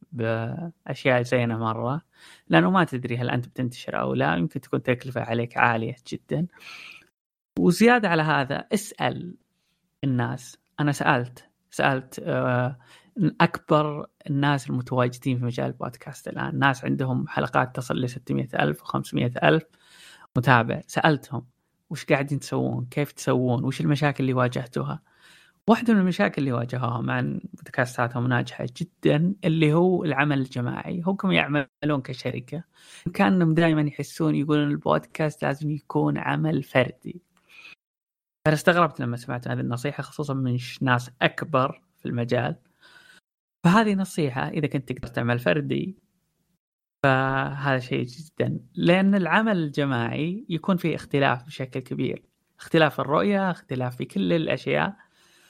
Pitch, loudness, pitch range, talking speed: 145 Hz, -24 LUFS, 125-165 Hz, 120 wpm